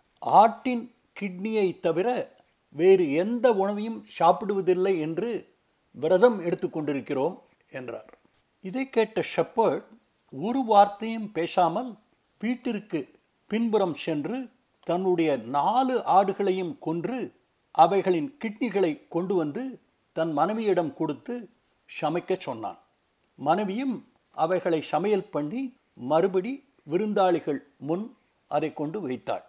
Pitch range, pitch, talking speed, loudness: 170-235 Hz, 195 Hz, 90 wpm, -26 LUFS